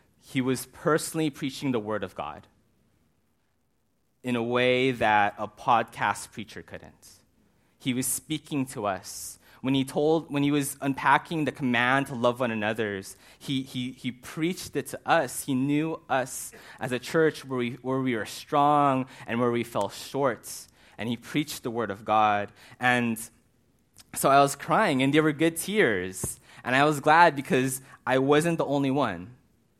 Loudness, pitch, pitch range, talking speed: -26 LUFS, 130 Hz, 120-145 Hz, 170 wpm